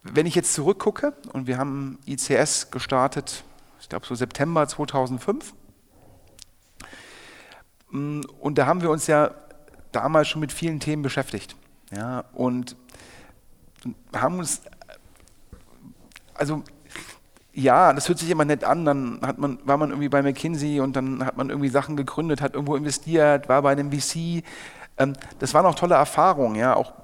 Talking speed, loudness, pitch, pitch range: 150 wpm, -23 LUFS, 140 Hz, 130-150 Hz